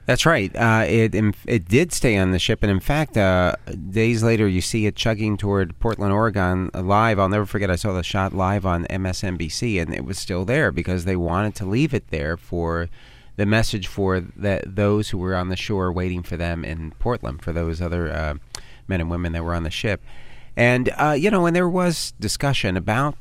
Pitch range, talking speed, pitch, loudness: 90-115 Hz, 215 wpm, 100 Hz, -21 LUFS